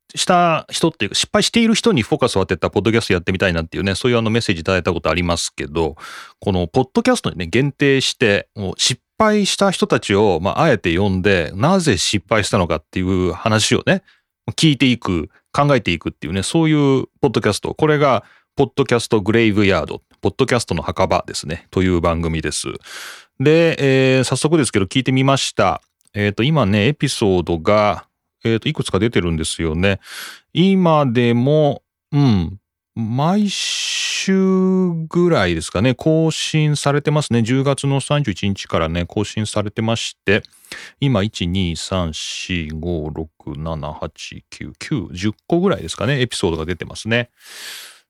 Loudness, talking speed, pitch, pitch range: -17 LUFS, 345 characters per minute, 115 Hz, 95-145 Hz